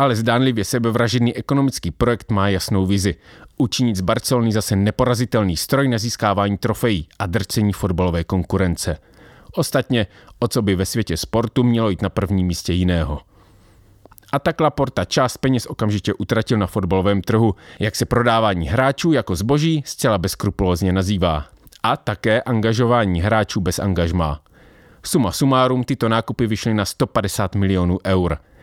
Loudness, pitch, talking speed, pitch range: -19 LUFS, 105 Hz, 145 wpm, 95-120 Hz